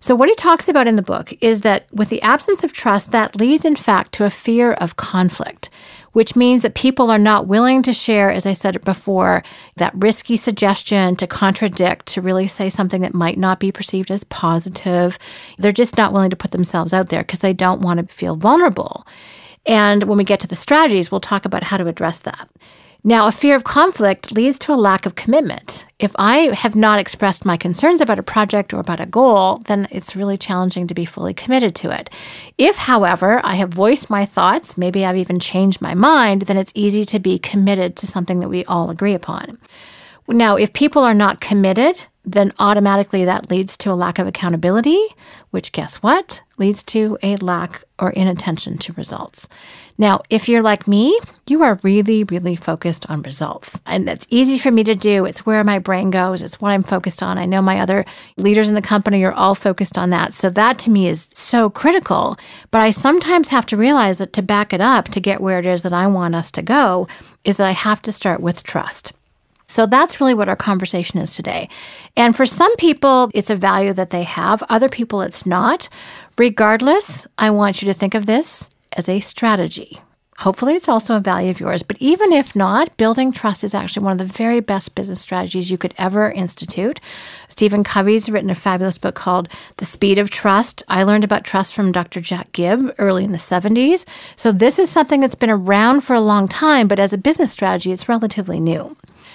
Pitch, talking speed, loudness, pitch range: 200 Hz, 210 wpm, -16 LUFS, 185-230 Hz